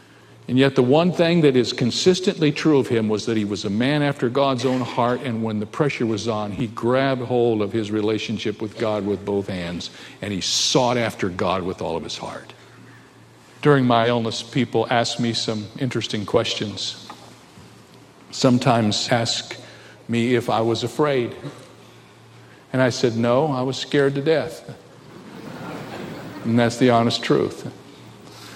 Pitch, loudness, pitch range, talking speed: 120 Hz, -21 LUFS, 115-130 Hz, 165 wpm